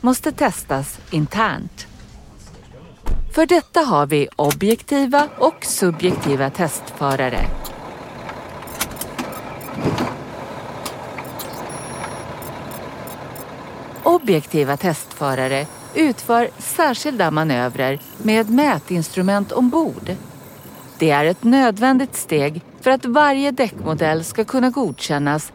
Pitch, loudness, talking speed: 180 Hz, -19 LUFS, 75 wpm